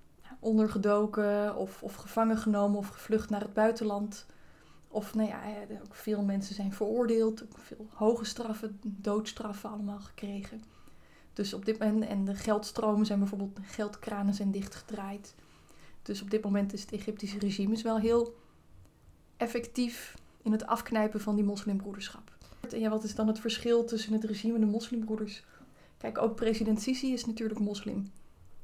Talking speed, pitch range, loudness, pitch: 155 wpm, 205-225 Hz, -32 LUFS, 215 Hz